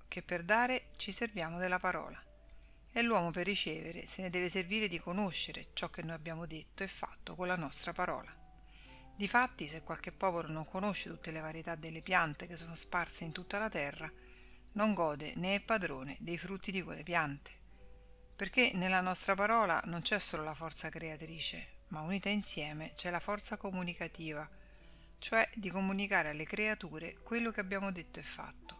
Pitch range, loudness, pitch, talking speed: 160-200 Hz, -37 LUFS, 175 Hz, 175 wpm